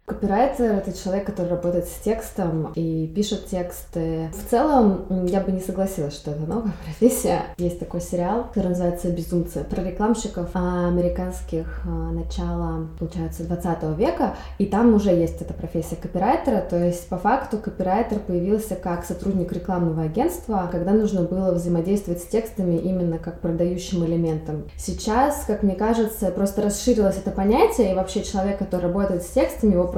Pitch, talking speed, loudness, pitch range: 185 Hz, 150 wpm, -23 LUFS, 175-205 Hz